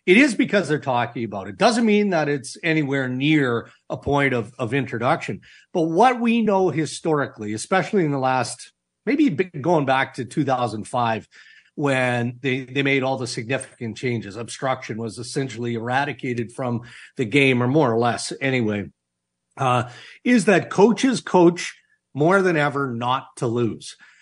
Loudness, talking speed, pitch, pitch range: -21 LUFS, 155 wpm, 135 Hz, 120-160 Hz